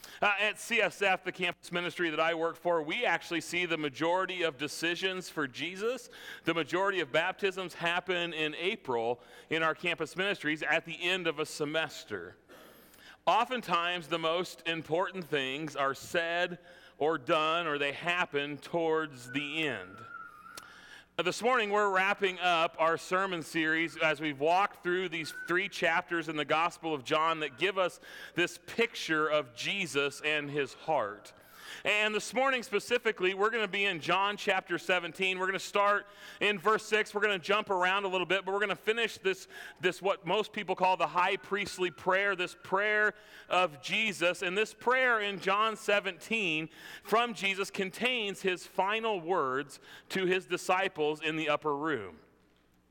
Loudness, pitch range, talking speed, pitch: -31 LUFS, 160-200 Hz, 165 wpm, 180 Hz